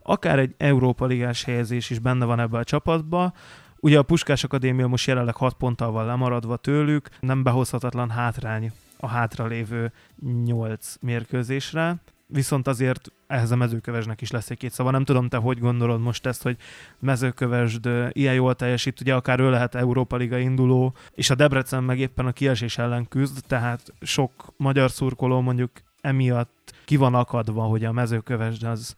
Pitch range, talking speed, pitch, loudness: 120-135 Hz, 165 wpm, 125 Hz, -23 LUFS